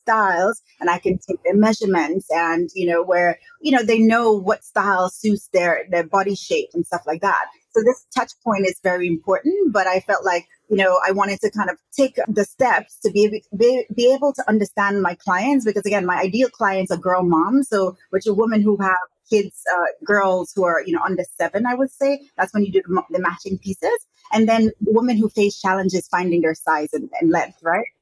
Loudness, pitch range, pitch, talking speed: -19 LUFS, 180-225 Hz, 200 Hz, 225 wpm